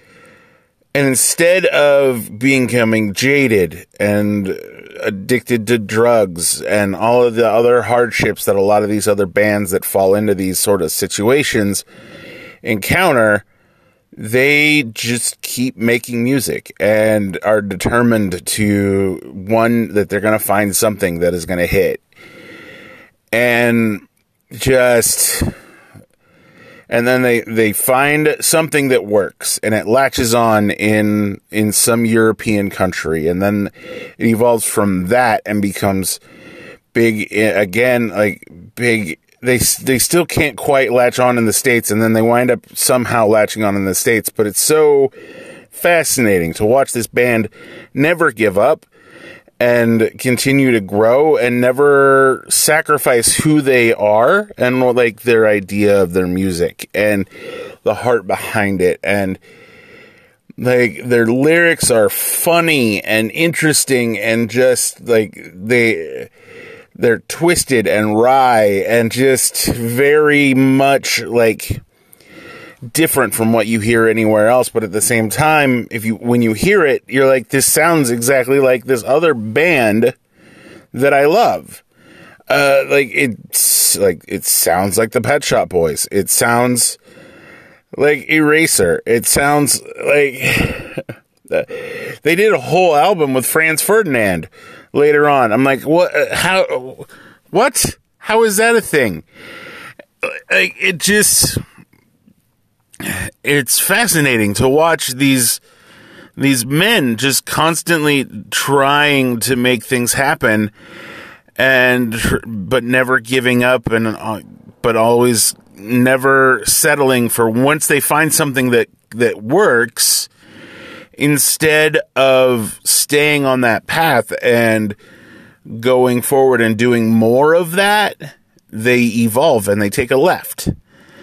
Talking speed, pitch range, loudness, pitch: 130 wpm, 110-145 Hz, -13 LUFS, 120 Hz